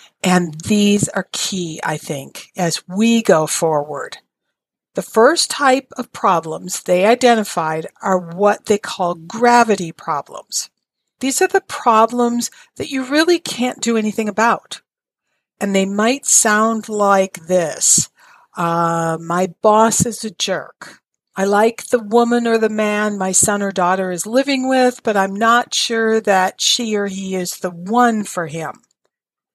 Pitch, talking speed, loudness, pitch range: 210 Hz, 150 wpm, -16 LUFS, 180-235 Hz